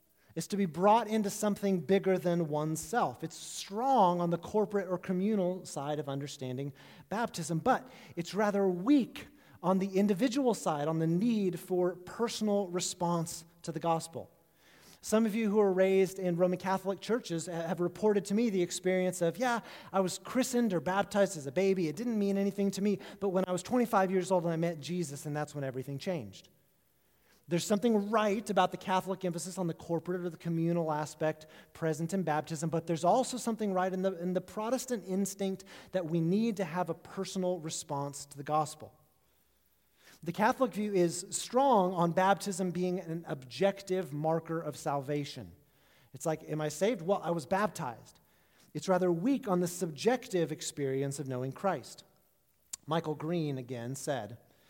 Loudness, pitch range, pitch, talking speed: -32 LUFS, 160-200 Hz, 180 Hz, 175 wpm